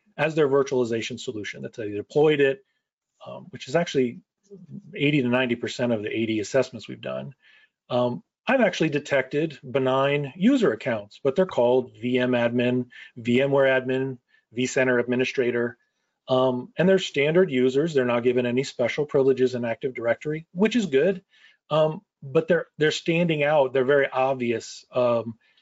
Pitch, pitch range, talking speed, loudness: 135 Hz, 125-155 Hz, 150 wpm, -24 LUFS